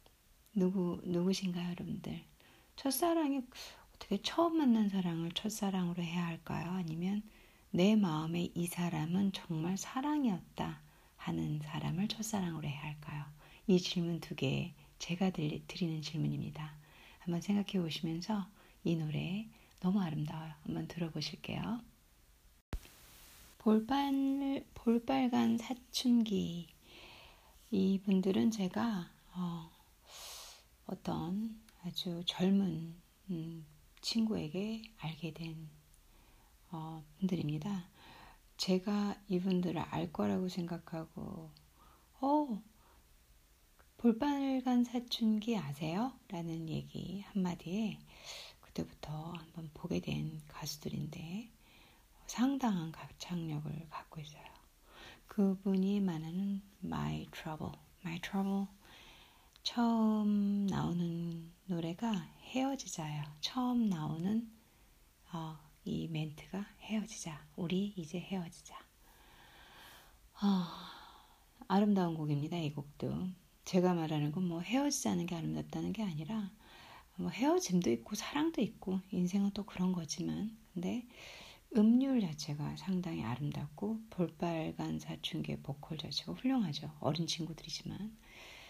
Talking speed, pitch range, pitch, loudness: 240 characters per minute, 160-210 Hz, 180 Hz, -37 LUFS